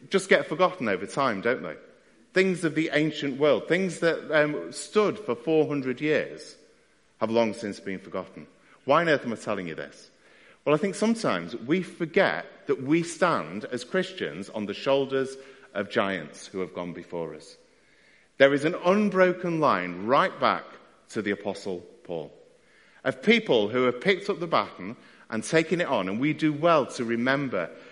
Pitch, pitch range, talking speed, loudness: 150 Hz, 125-180 Hz, 175 wpm, -26 LUFS